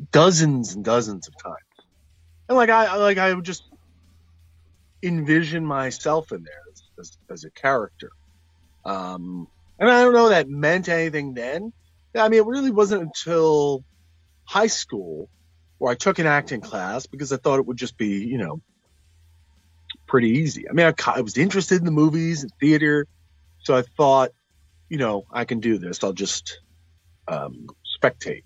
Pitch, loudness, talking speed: 125 Hz, -21 LUFS, 170 wpm